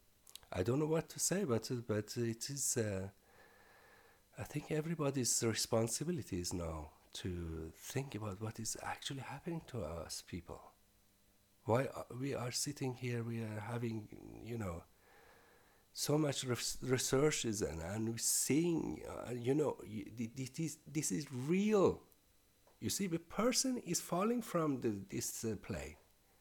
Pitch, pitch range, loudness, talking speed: 115 Hz, 100-145 Hz, -38 LUFS, 150 wpm